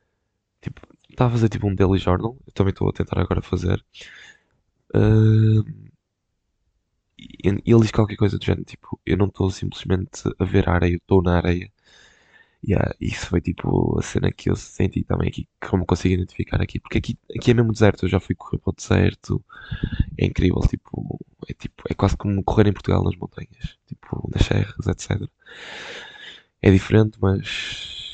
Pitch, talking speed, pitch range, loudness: 100 Hz, 180 wpm, 95-110 Hz, -22 LUFS